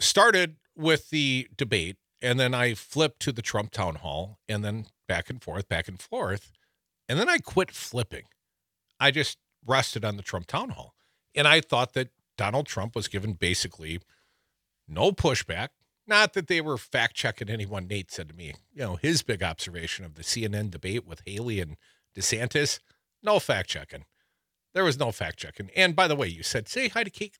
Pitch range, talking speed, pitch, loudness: 95-140 Hz, 190 wpm, 110 Hz, -27 LUFS